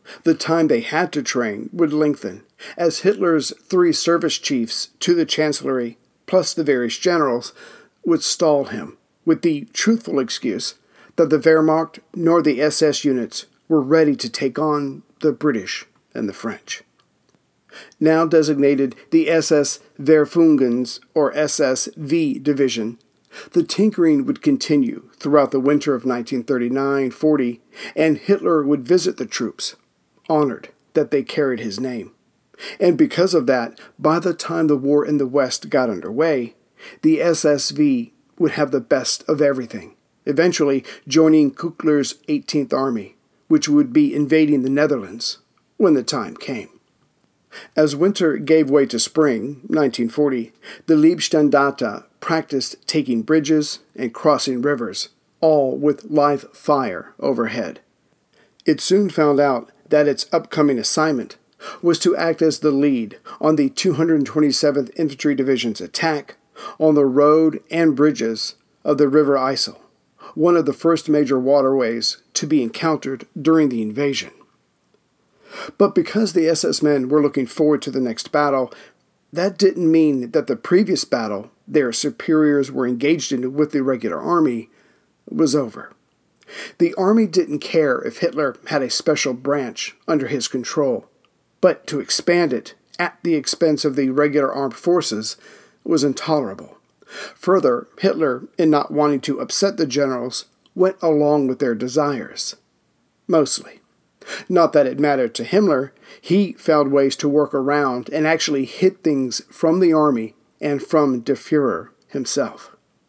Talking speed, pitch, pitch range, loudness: 140 wpm, 150 Hz, 140-170 Hz, -19 LUFS